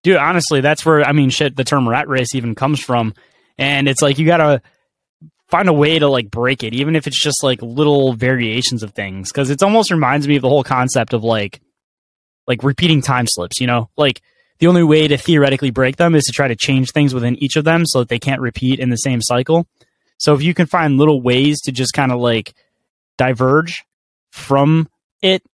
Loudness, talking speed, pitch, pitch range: -15 LUFS, 225 wpm, 140 Hz, 125-150 Hz